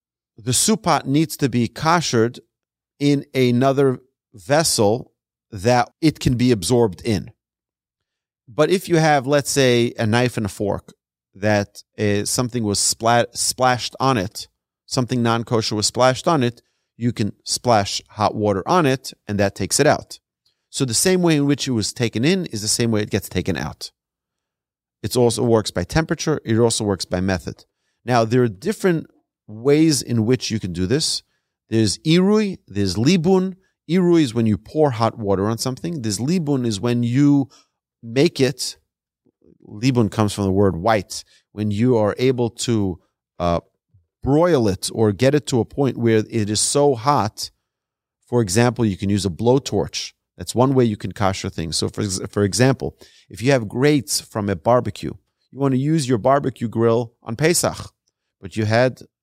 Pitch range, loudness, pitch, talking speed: 105-135 Hz, -19 LUFS, 120 Hz, 175 wpm